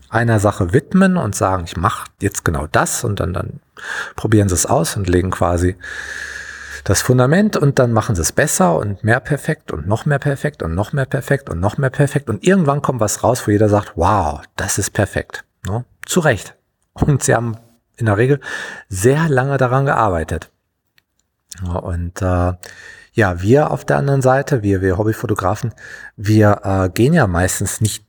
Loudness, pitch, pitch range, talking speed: -17 LUFS, 110 Hz, 100-140 Hz, 185 wpm